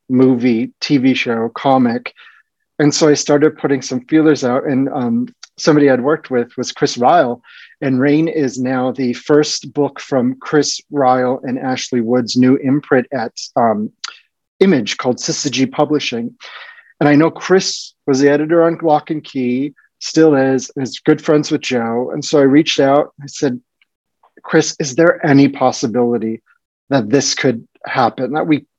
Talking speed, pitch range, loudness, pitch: 165 wpm, 130-155 Hz, -15 LUFS, 140 Hz